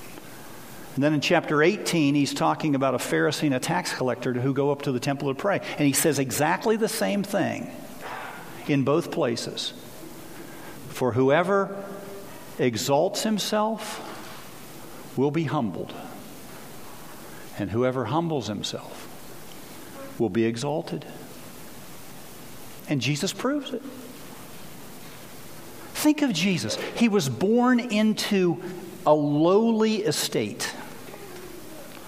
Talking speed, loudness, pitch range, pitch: 110 wpm, -25 LUFS, 140-205 Hz, 160 Hz